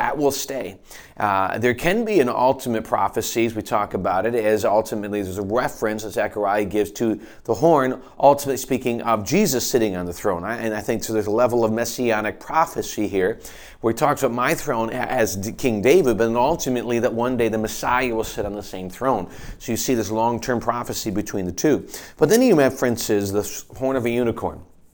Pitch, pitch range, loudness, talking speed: 115 Hz, 105-125 Hz, -21 LUFS, 205 wpm